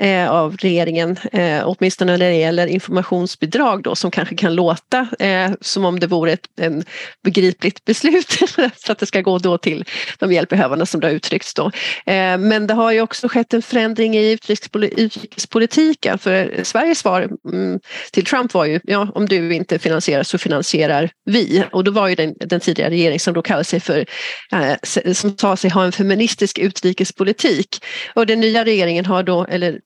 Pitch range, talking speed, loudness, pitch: 175-220 Hz, 180 wpm, -17 LUFS, 190 Hz